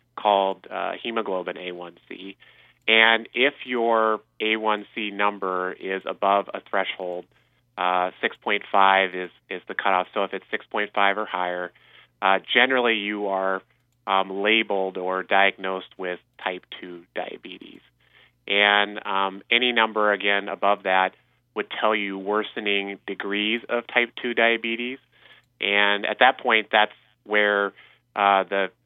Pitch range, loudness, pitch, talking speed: 95-110 Hz, -23 LUFS, 100 Hz, 125 wpm